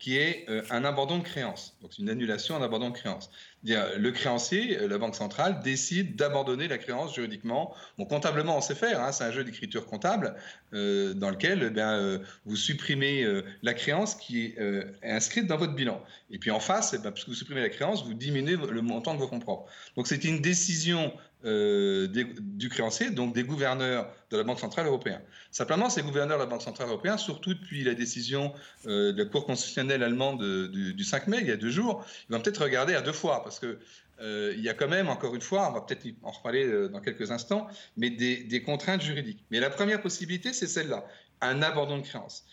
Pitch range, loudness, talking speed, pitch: 125-195 Hz, -30 LUFS, 220 wpm, 145 Hz